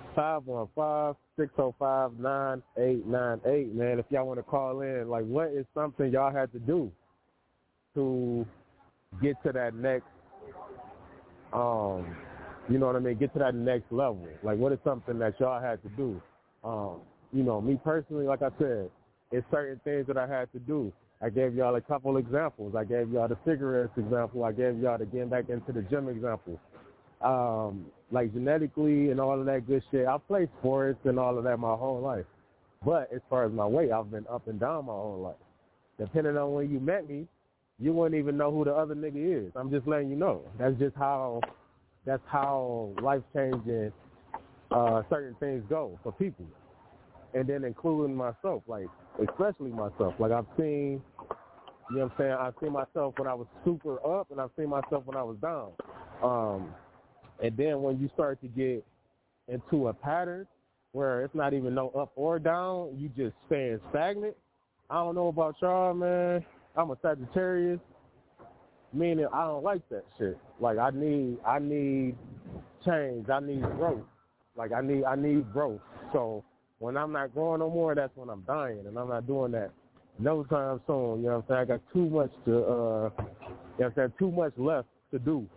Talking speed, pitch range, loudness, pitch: 190 wpm, 120-145 Hz, -31 LUFS, 130 Hz